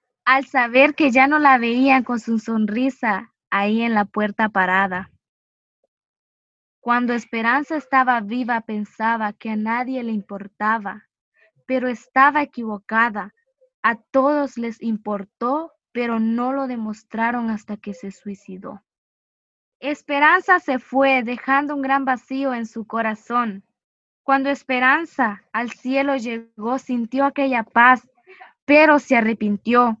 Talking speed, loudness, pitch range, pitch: 120 wpm, -19 LUFS, 220-265 Hz, 240 Hz